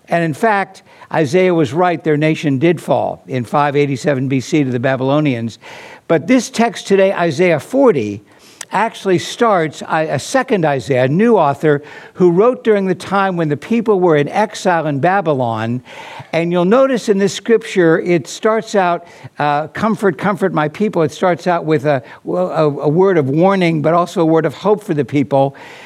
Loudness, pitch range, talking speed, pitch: -15 LUFS, 150-195 Hz, 175 wpm, 170 Hz